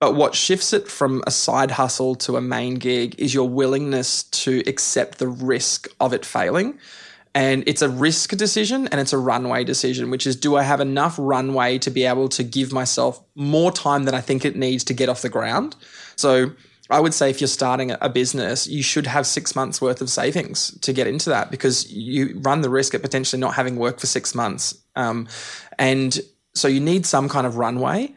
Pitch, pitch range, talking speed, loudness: 135 Hz, 130-145 Hz, 215 wpm, -20 LUFS